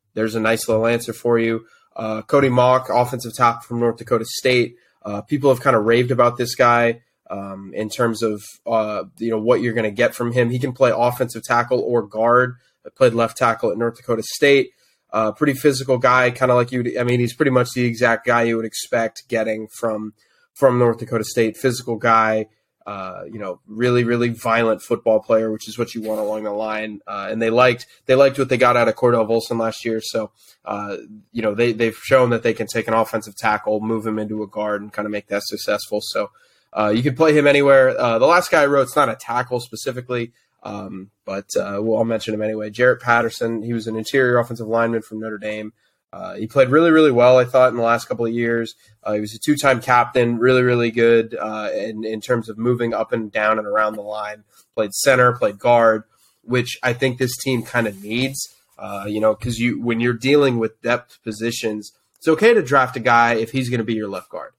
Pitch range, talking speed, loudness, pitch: 110-125 Hz, 230 wpm, -19 LUFS, 115 Hz